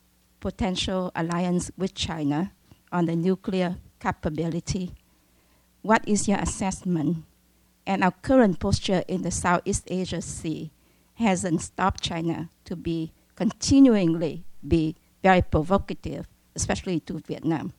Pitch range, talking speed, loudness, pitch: 160-190 Hz, 110 wpm, -25 LUFS, 170 Hz